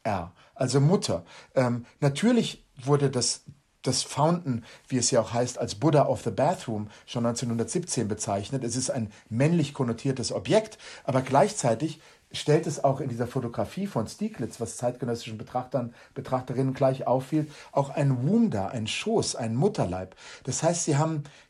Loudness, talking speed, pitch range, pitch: -27 LUFS, 150 wpm, 120-150 Hz, 135 Hz